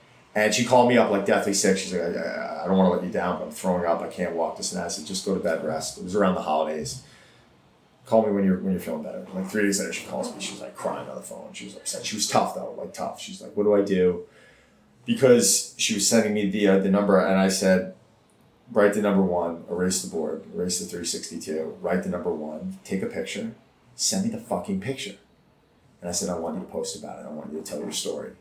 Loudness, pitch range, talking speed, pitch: -25 LUFS, 90-105 Hz, 275 wpm, 95 Hz